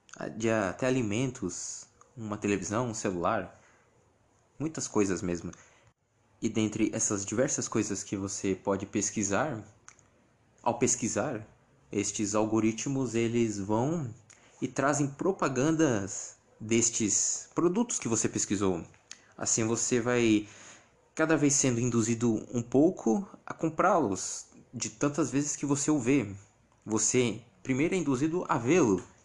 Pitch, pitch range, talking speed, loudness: 115 Hz, 105-130 Hz, 115 wpm, -29 LUFS